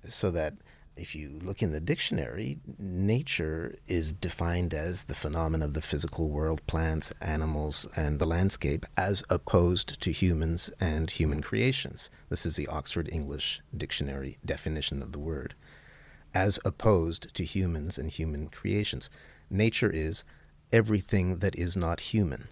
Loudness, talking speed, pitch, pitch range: -31 LUFS, 145 wpm, 85 Hz, 75-95 Hz